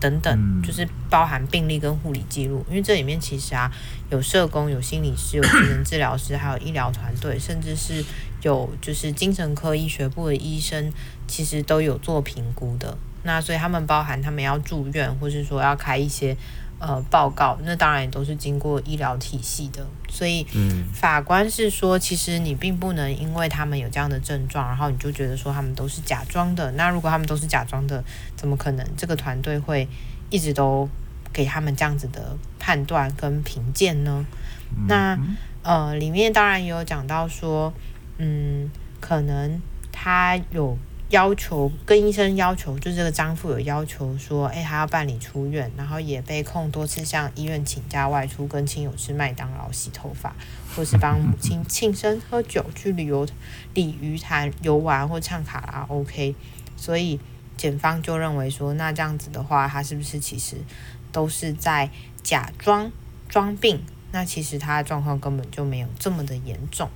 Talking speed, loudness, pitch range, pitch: 270 characters per minute, -23 LUFS, 135-160 Hz, 145 Hz